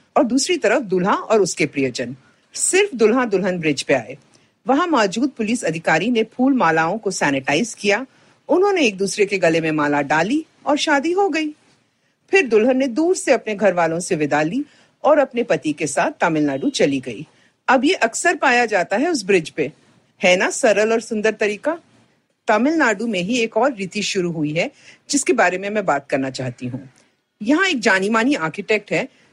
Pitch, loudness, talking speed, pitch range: 215 Hz, -18 LUFS, 185 wpm, 170-280 Hz